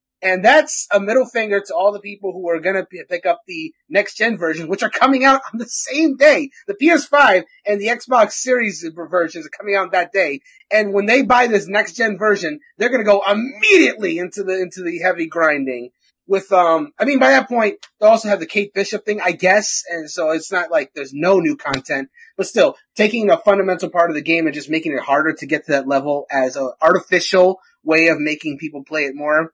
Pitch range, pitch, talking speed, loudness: 165-250 Hz, 200 Hz, 220 wpm, -16 LUFS